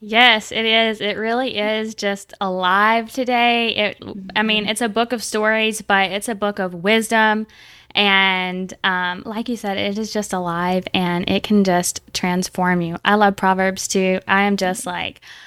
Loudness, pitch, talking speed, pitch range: -18 LUFS, 205 Hz, 180 wpm, 185-220 Hz